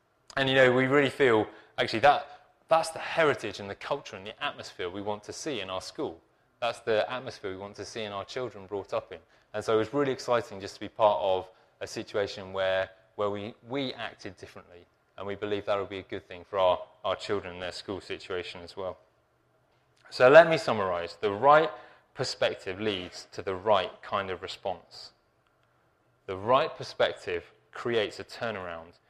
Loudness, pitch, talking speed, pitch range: -29 LUFS, 105 Hz, 195 wpm, 100-130 Hz